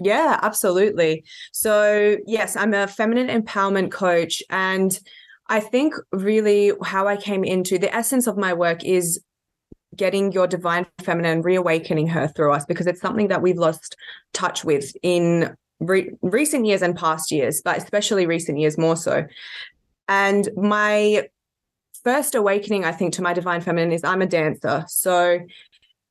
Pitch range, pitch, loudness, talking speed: 170-205 Hz, 190 Hz, -20 LUFS, 155 wpm